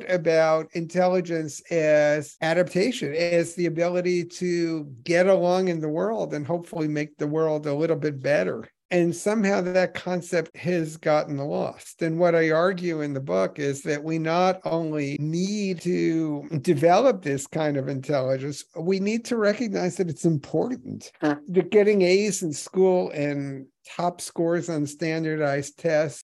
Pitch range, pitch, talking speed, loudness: 150-180 Hz, 165 Hz, 150 wpm, -24 LUFS